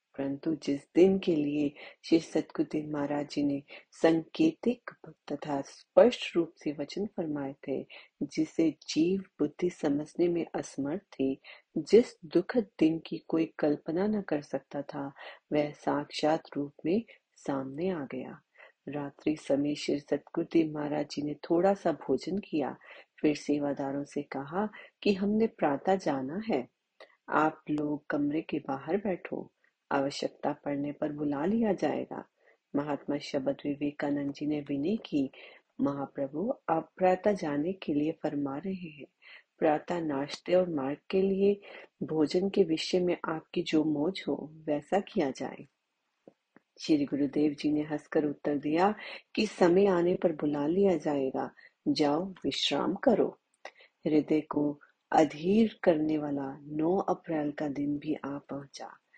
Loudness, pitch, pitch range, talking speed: -31 LUFS, 155 Hz, 145-185 Hz, 135 wpm